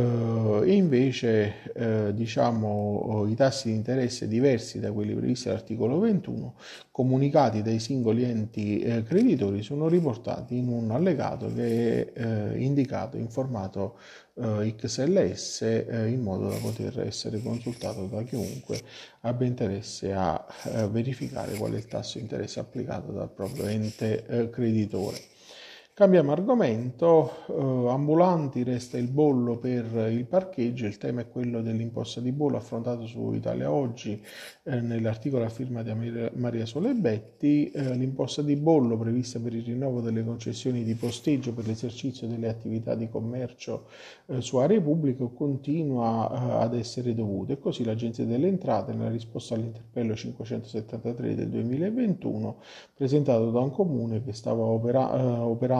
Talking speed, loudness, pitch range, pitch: 145 wpm, -28 LUFS, 115-130 Hz, 120 Hz